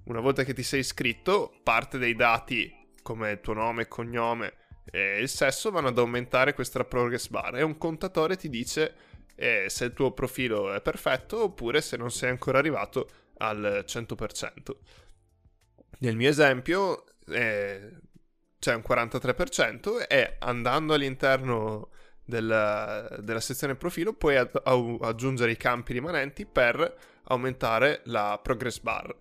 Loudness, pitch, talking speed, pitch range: -28 LUFS, 125 Hz, 140 wpm, 115-140 Hz